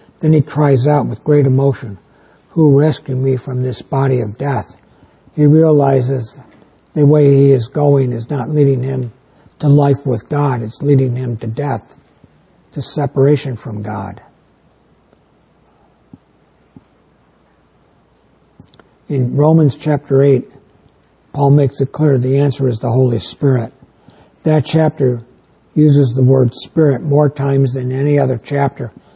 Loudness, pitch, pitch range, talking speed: -14 LUFS, 135 Hz, 130-145 Hz, 135 wpm